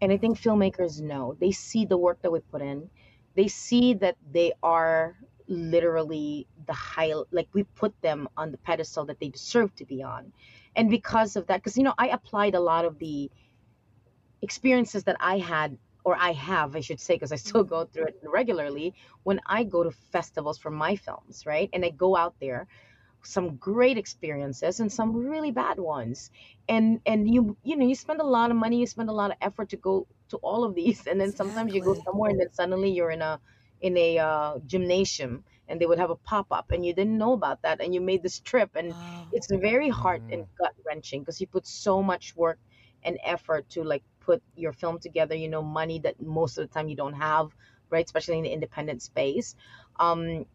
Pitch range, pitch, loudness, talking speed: 155-200 Hz, 170 Hz, -27 LUFS, 215 wpm